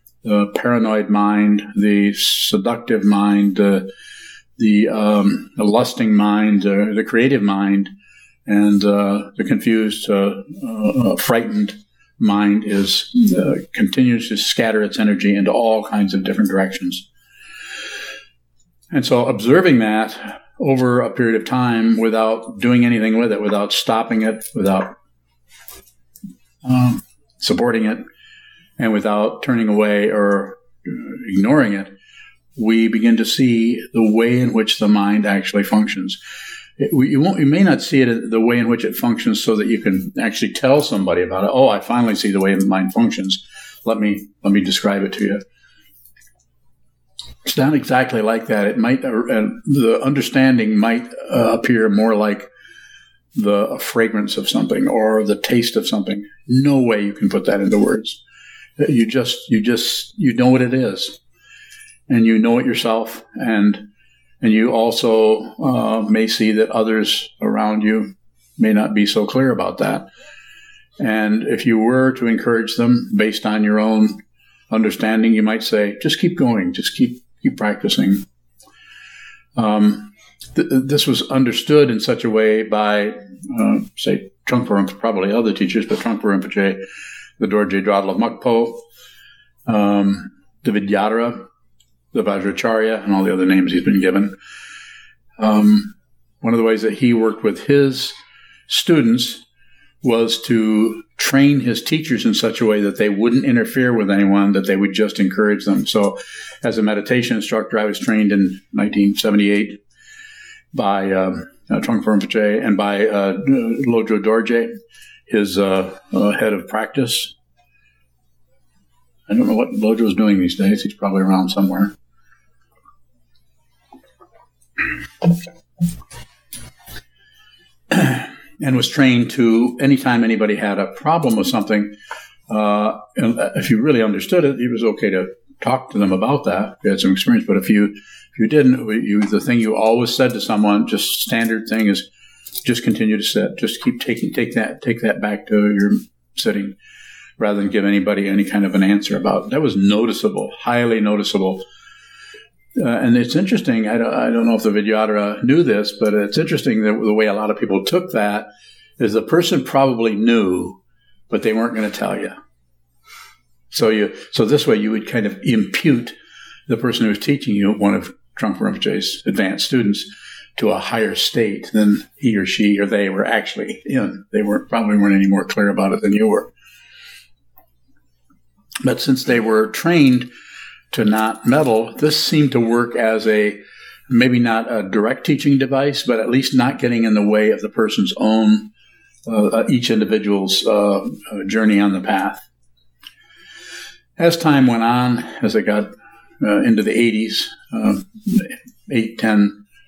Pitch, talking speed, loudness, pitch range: 110 Hz, 160 wpm, -17 LUFS, 100-125 Hz